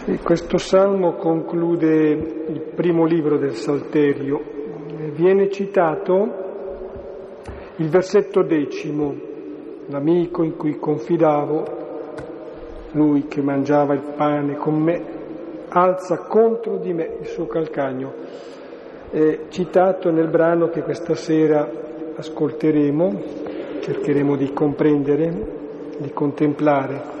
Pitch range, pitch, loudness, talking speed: 150-175 Hz, 155 Hz, -20 LUFS, 95 wpm